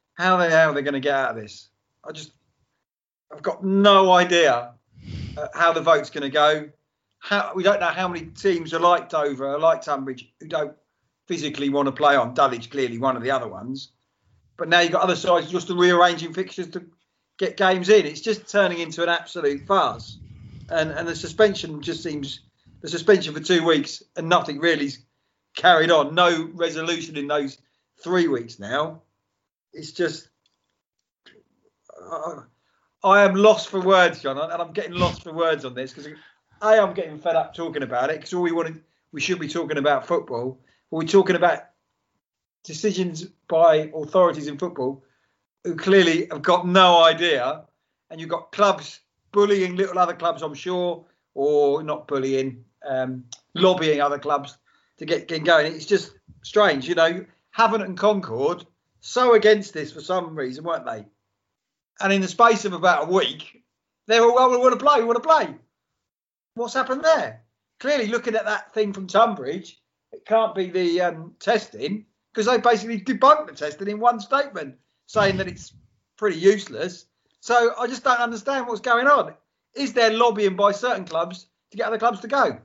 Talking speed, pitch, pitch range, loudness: 180 wpm, 170 Hz, 150-200 Hz, -21 LUFS